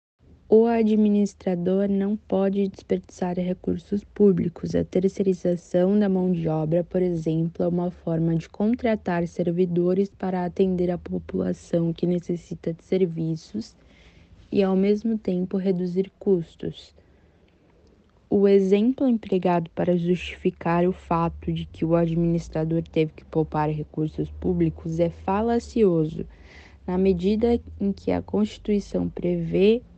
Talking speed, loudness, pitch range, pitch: 120 wpm, -24 LUFS, 165-195 Hz, 180 Hz